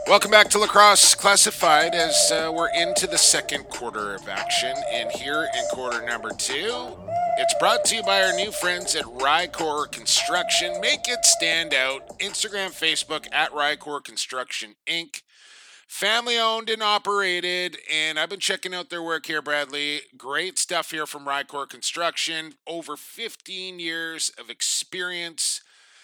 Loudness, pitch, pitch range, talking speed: -21 LUFS, 180 Hz, 155-215 Hz, 150 wpm